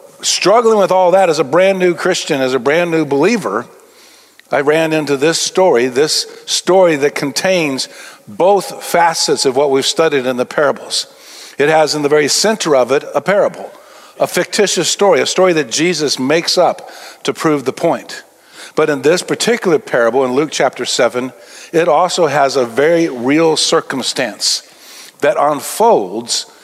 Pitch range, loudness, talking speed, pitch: 145-185 Hz, -13 LUFS, 165 wpm, 165 Hz